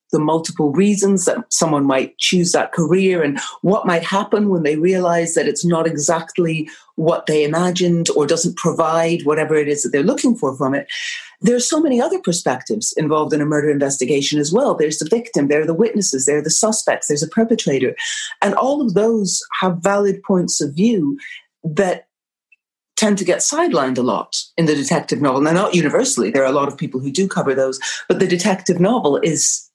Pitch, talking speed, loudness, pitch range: 175 Hz, 200 wpm, -17 LUFS, 155-205 Hz